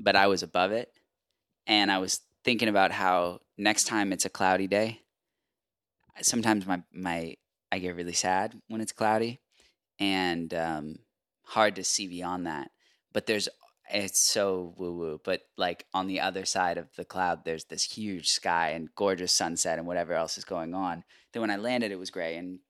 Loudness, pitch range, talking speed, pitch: -29 LUFS, 90-105 Hz, 185 wpm, 95 Hz